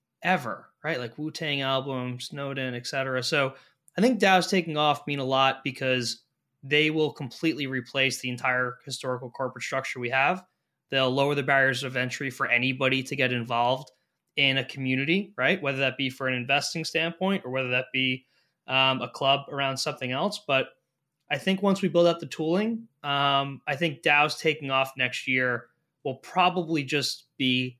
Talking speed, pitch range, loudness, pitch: 175 wpm, 130-155 Hz, -26 LUFS, 135 Hz